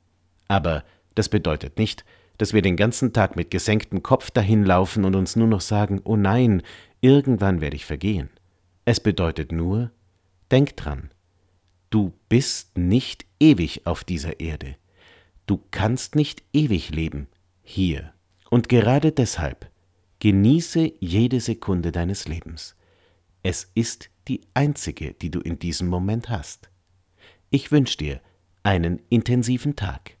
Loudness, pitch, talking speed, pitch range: -22 LUFS, 95 Hz, 130 wpm, 90-115 Hz